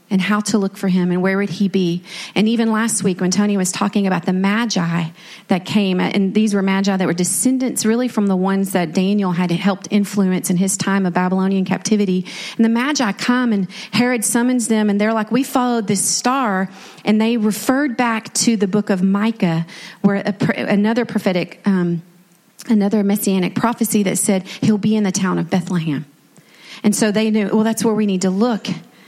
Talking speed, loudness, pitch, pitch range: 200 wpm, -17 LUFS, 200 Hz, 185-220 Hz